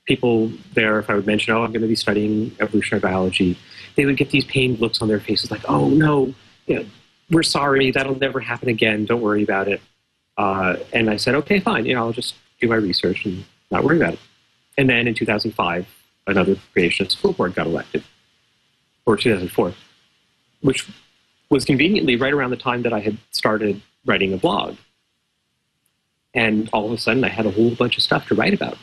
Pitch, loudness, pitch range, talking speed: 115 Hz, -19 LUFS, 105-130 Hz, 200 wpm